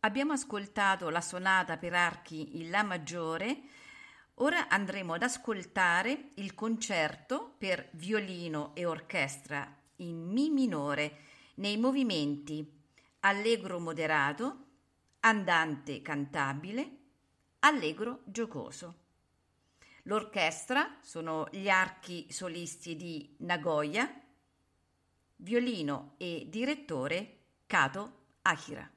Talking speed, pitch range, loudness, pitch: 85 wpm, 150-220 Hz, -33 LUFS, 175 Hz